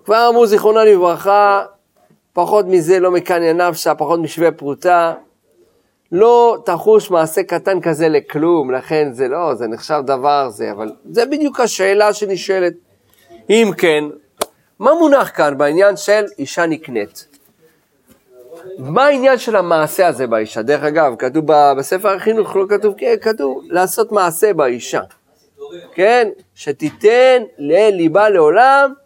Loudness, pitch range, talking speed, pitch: -14 LUFS, 155-235 Hz, 125 wpm, 185 Hz